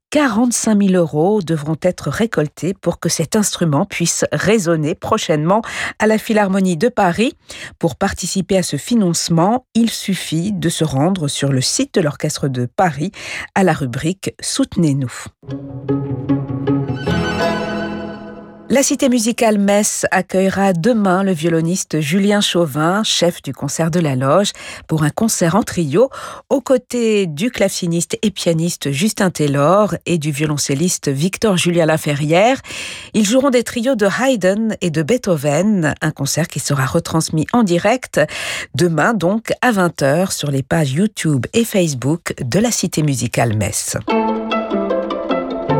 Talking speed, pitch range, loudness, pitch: 140 wpm, 155-215 Hz, -16 LUFS, 180 Hz